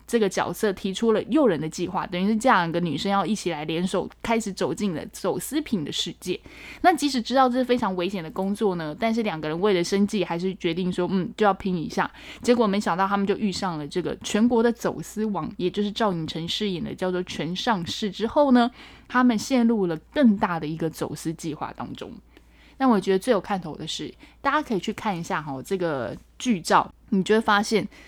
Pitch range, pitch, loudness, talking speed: 175-230 Hz, 200 Hz, -24 LUFS, 325 characters per minute